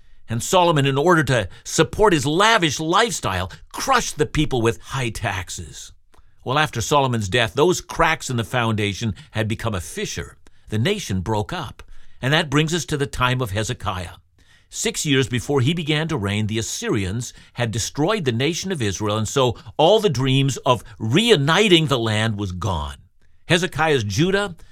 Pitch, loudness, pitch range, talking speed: 125 Hz, -20 LUFS, 105-155 Hz, 170 wpm